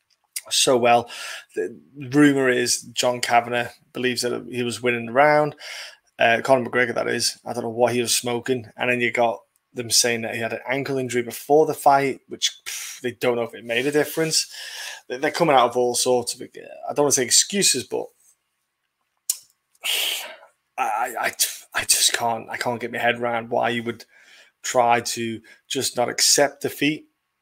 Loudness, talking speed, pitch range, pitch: -21 LUFS, 180 wpm, 120-145 Hz, 125 Hz